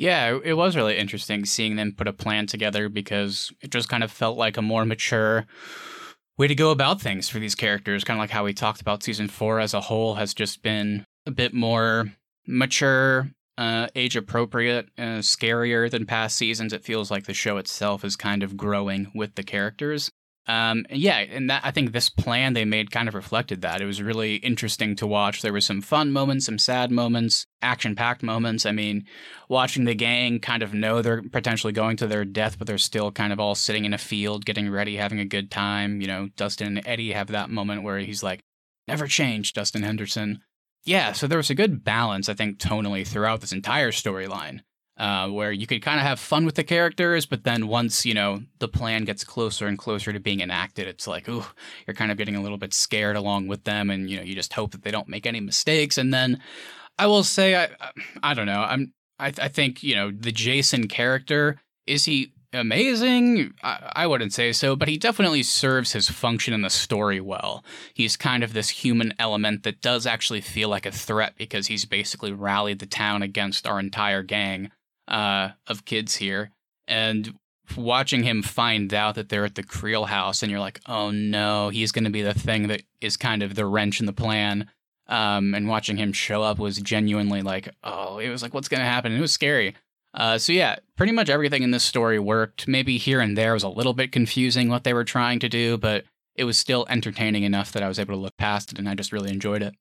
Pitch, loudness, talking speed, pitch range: 110 Hz, -23 LUFS, 220 wpm, 105-120 Hz